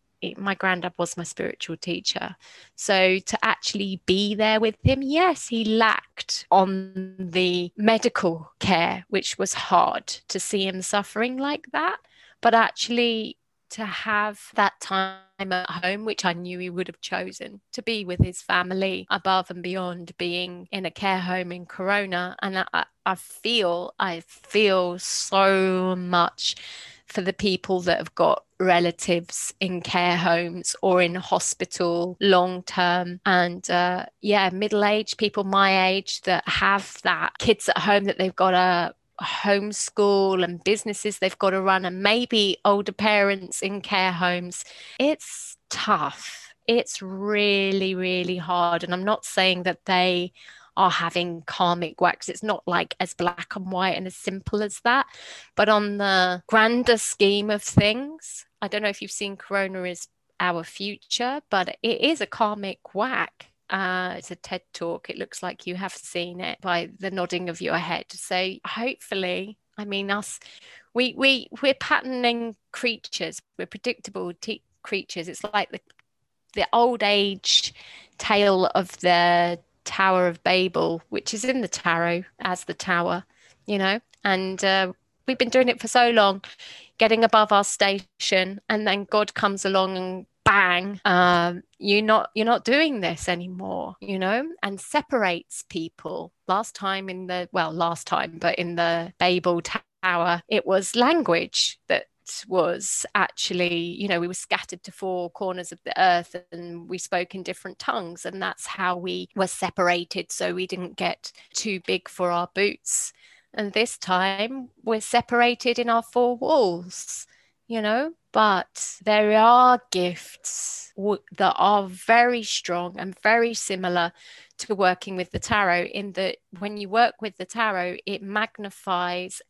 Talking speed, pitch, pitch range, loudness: 160 wpm, 190 Hz, 180-210 Hz, -23 LUFS